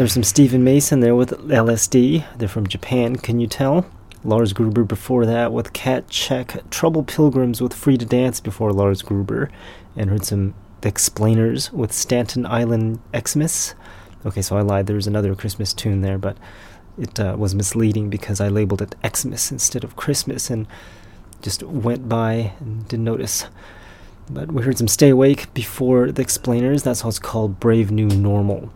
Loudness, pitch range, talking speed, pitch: -19 LUFS, 100-125 Hz, 175 wpm, 110 Hz